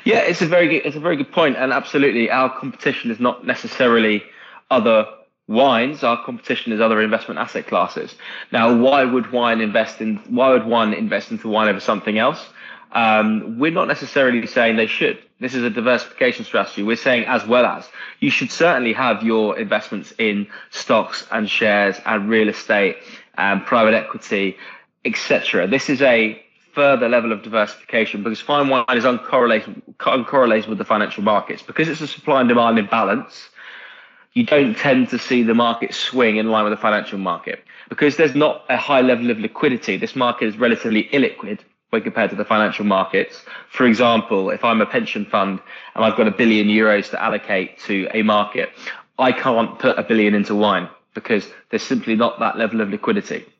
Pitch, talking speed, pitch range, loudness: 115 Hz, 185 wpm, 110-125 Hz, -18 LUFS